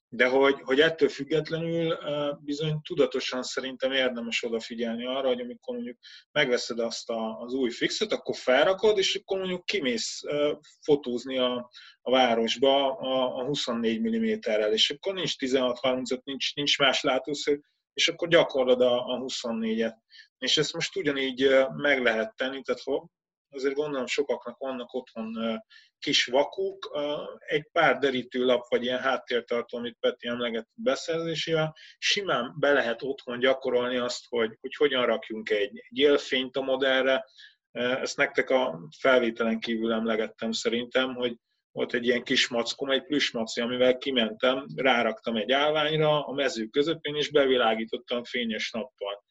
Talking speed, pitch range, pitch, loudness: 135 wpm, 120-150 Hz, 130 Hz, -27 LUFS